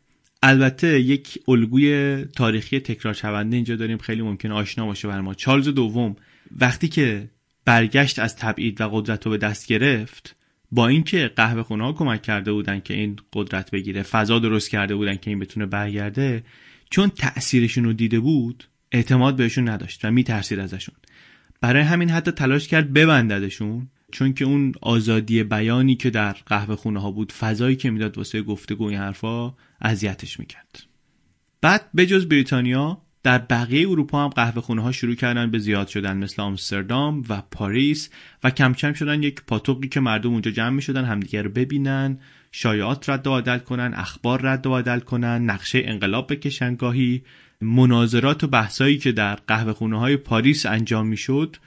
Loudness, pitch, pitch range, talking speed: -21 LUFS, 120 Hz, 110-135 Hz, 165 wpm